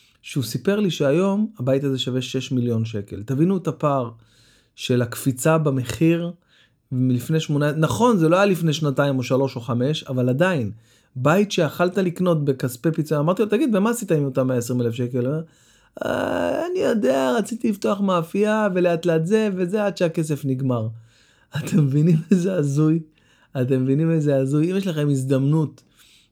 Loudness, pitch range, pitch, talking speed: -21 LUFS, 130-180 Hz, 150 Hz, 160 wpm